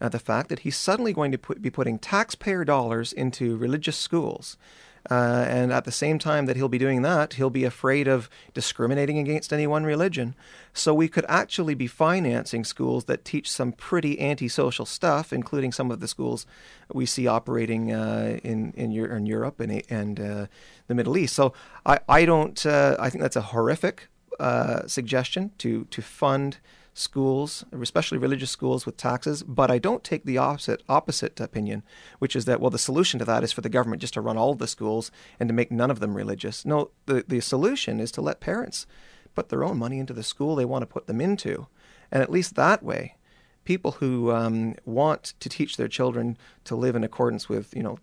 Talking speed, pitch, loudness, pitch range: 205 wpm, 130 Hz, -25 LUFS, 115-150 Hz